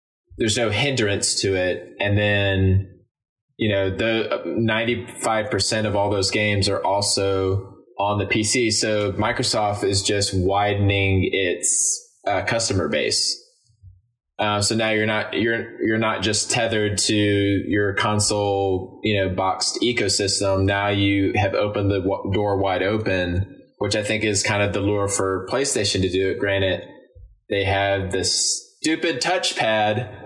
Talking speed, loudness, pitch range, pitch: 150 wpm, -21 LUFS, 95-110 Hz, 105 Hz